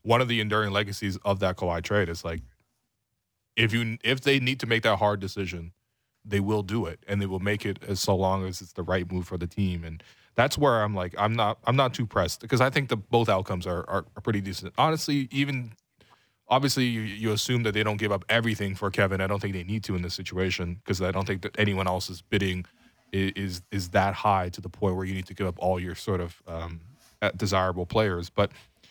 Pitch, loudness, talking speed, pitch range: 100 Hz, -27 LUFS, 240 wpm, 95-115 Hz